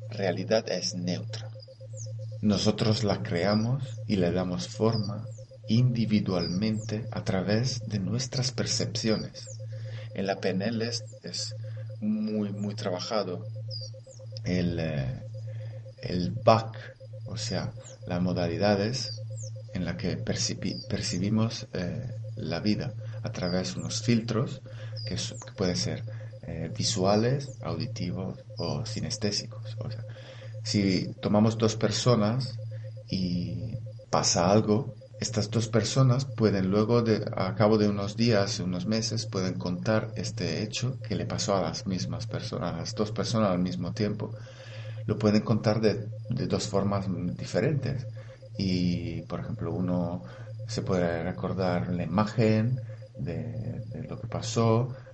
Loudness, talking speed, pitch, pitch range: -29 LUFS, 125 wpm, 110 Hz, 105-110 Hz